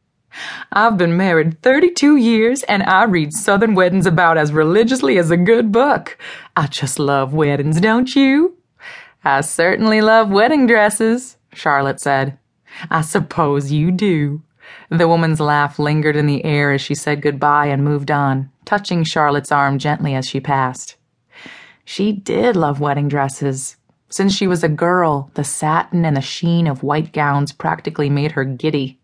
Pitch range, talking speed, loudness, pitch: 145-200 Hz, 165 wpm, -15 LUFS, 155 Hz